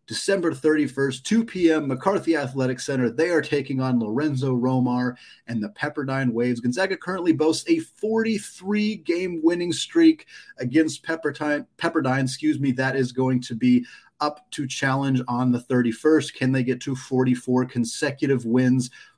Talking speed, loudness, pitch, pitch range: 155 wpm, -23 LUFS, 140 Hz, 125-165 Hz